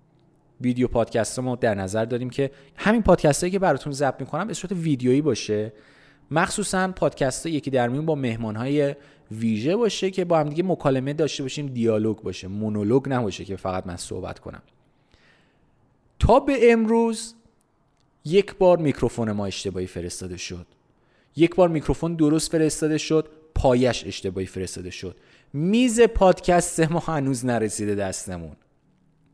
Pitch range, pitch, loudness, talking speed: 110-165 Hz, 140 Hz, -23 LUFS, 145 wpm